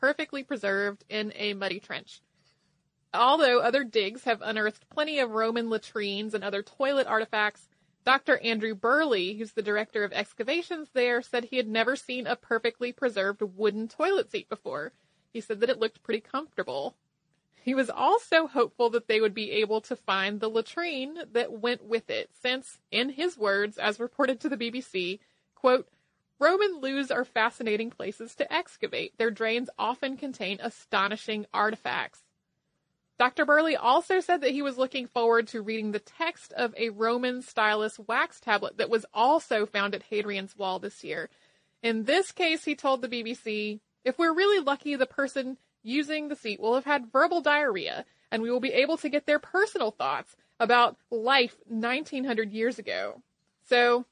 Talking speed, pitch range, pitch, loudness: 170 wpm, 215-275 Hz, 235 Hz, -28 LUFS